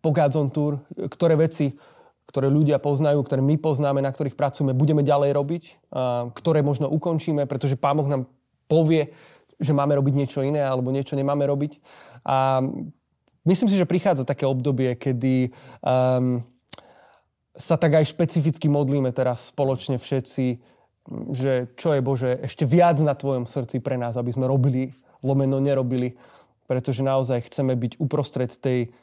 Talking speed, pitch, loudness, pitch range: 145 wpm, 140 Hz, -23 LUFS, 130-150 Hz